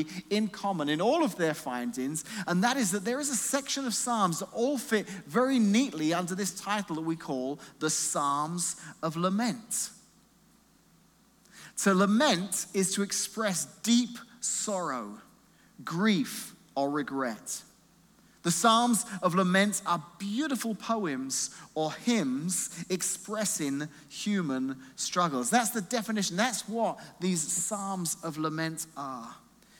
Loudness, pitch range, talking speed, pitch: -30 LUFS, 160-225 Hz, 130 wpm, 195 Hz